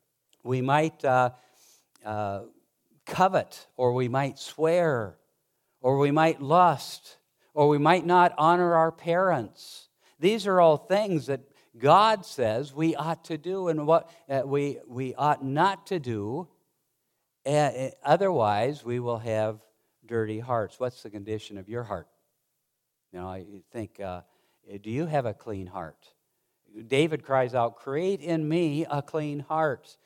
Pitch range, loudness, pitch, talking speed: 115-160 Hz, -26 LUFS, 140 Hz, 145 wpm